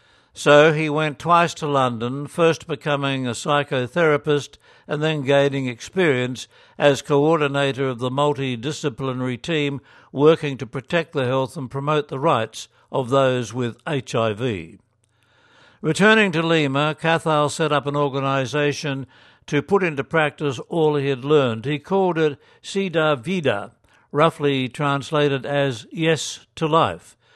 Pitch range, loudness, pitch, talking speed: 135-155 Hz, -21 LUFS, 145 Hz, 130 wpm